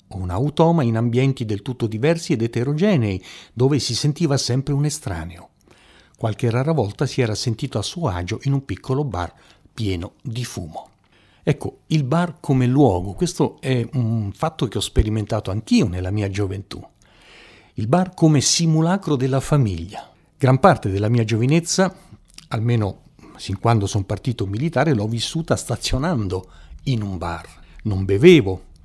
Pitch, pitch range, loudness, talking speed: 120 Hz, 100-145 Hz, -20 LUFS, 150 wpm